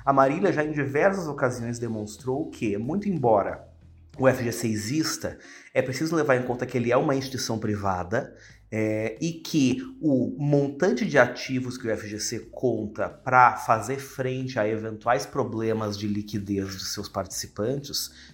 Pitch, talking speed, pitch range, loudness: 120 Hz, 150 wpm, 105-140 Hz, -26 LUFS